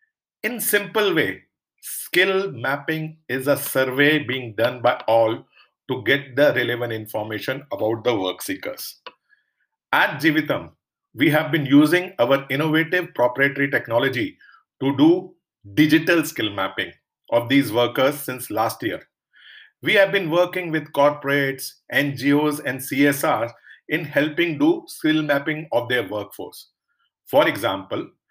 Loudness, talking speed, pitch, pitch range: -21 LUFS, 130 wpm, 145 Hz, 130-165 Hz